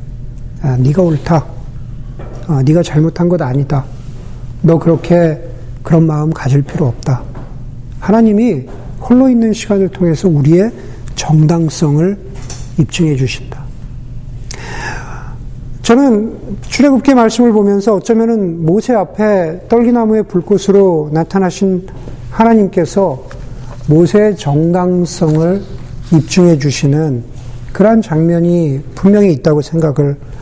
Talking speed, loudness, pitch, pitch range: 240 characters per minute, -11 LUFS, 155 Hz, 130-190 Hz